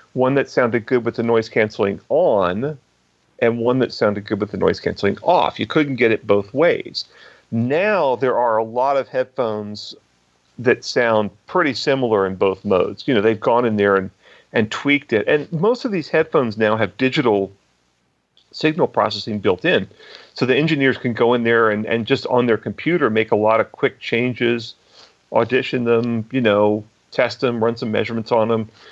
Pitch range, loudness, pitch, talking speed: 105-125 Hz, -19 LUFS, 115 Hz, 190 wpm